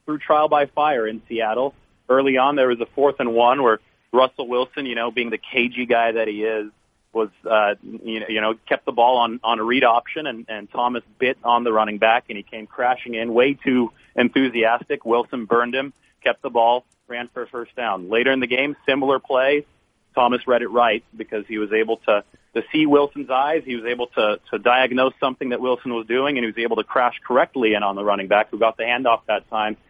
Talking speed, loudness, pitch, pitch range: 230 wpm, -20 LUFS, 120 Hz, 110-130 Hz